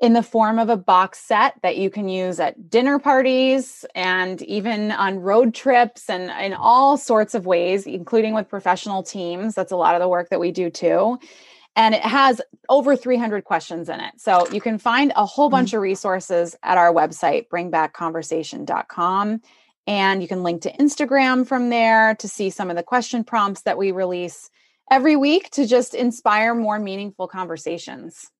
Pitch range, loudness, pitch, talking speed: 185-250 Hz, -19 LUFS, 210 Hz, 180 wpm